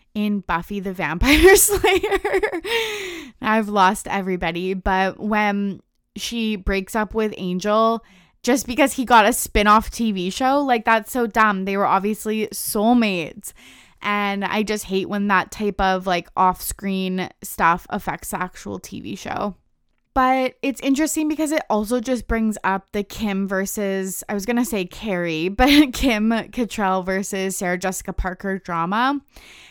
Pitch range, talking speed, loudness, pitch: 190-245 Hz, 150 wpm, -20 LUFS, 210 Hz